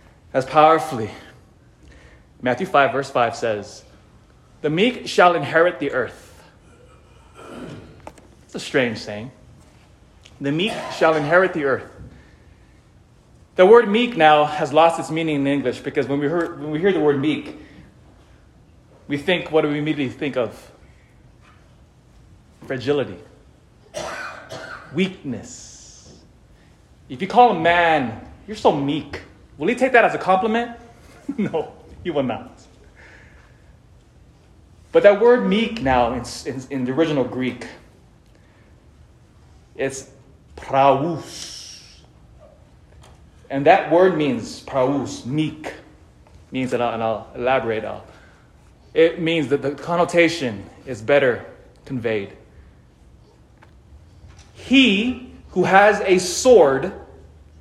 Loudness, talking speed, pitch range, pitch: -19 LUFS, 110 wpm, 120-175 Hz, 145 Hz